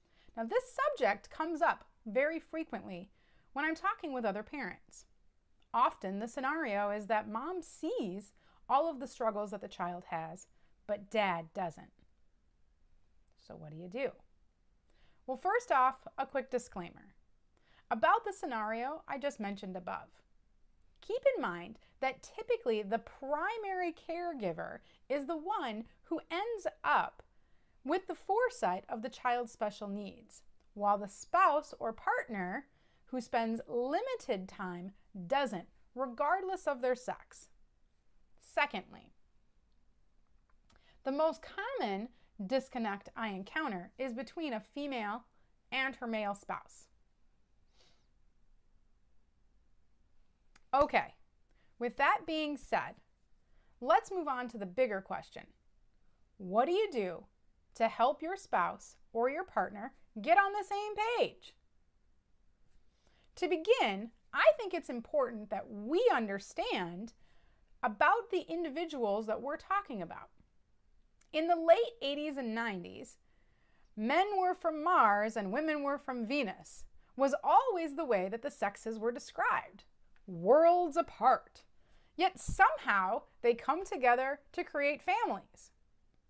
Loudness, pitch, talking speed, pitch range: -35 LUFS, 265 Hz, 125 wpm, 215-335 Hz